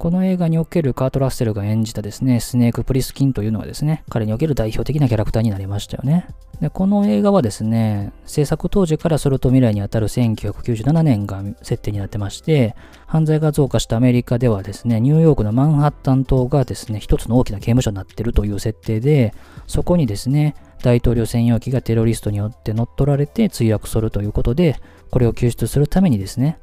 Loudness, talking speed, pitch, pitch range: -18 LUFS, 455 characters per minute, 125 Hz, 110-145 Hz